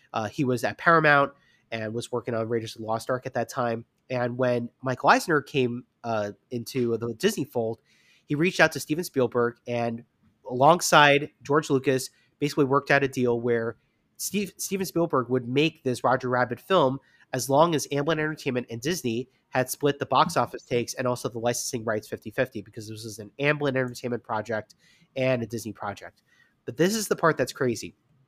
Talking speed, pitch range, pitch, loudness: 190 wpm, 115-145 Hz, 125 Hz, -26 LUFS